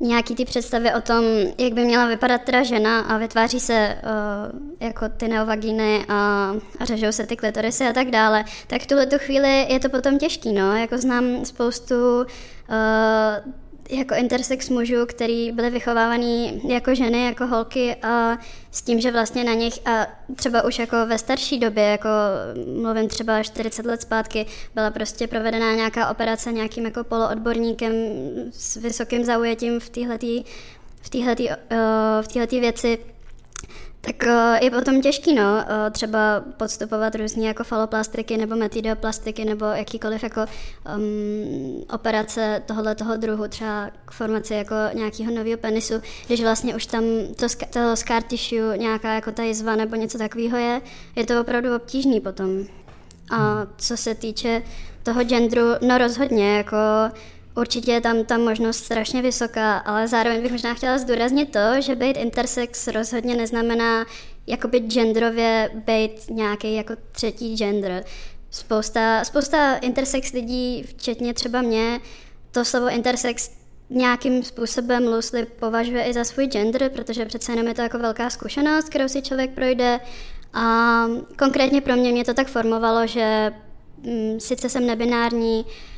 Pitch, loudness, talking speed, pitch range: 230 Hz, -22 LUFS, 150 wpm, 220-245 Hz